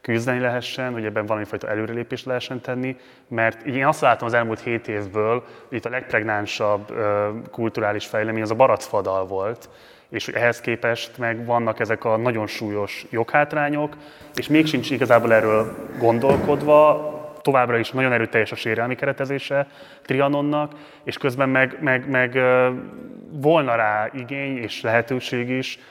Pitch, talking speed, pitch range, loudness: 125 Hz, 145 wpm, 115-140 Hz, -21 LUFS